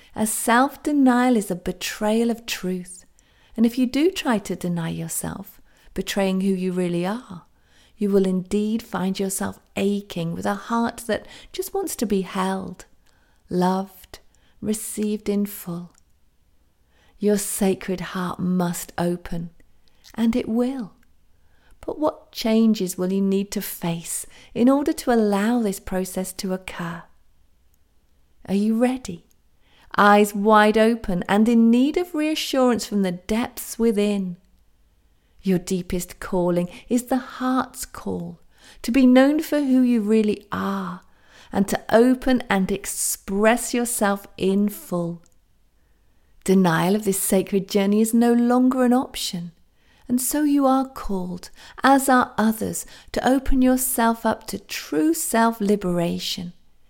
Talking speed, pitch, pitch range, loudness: 135 wpm, 200 Hz, 180-235 Hz, -22 LUFS